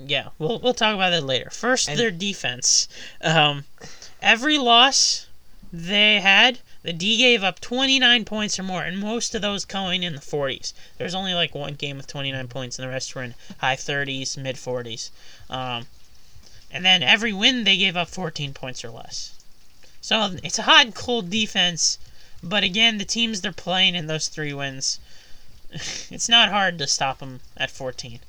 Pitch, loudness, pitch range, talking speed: 175 Hz, -20 LUFS, 135-215 Hz, 185 wpm